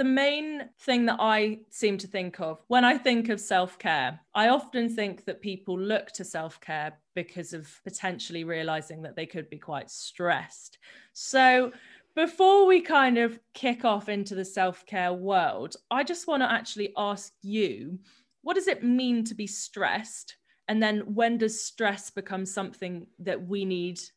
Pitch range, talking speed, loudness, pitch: 185-245 Hz, 175 wpm, -27 LUFS, 210 Hz